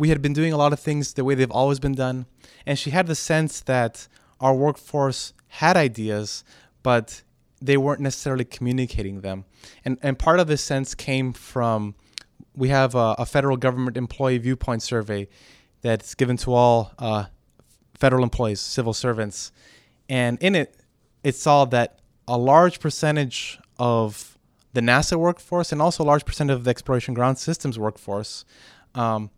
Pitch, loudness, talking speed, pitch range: 130 Hz, -22 LUFS, 165 wpm, 115-140 Hz